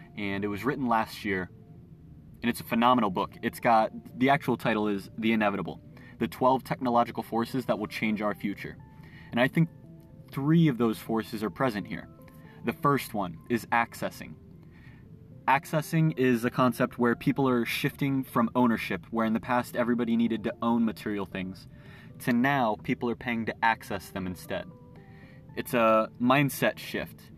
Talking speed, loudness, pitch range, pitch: 165 wpm, -28 LUFS, 110-130 Hz, 120 Hz